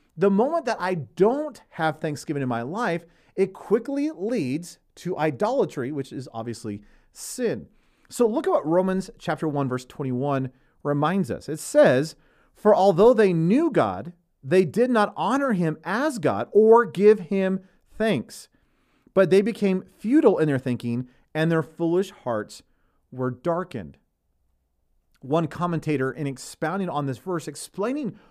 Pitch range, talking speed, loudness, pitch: 140-200 Hz, 145 wpm, -23 LUFS, 170 Hz